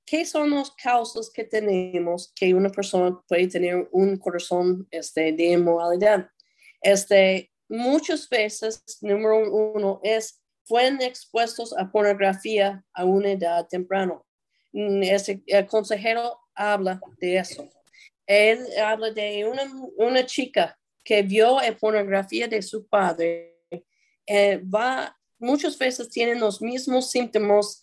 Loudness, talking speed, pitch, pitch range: -23 LUFS, 125 wpm, 210 Hz, 185-230 Hz